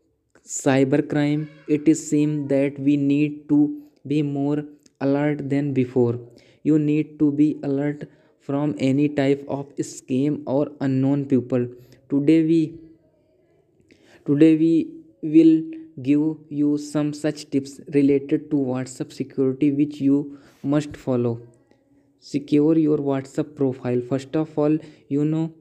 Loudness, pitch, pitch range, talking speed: -22 LUFS, 145 Hz, 140-150 Hz, 125 wpm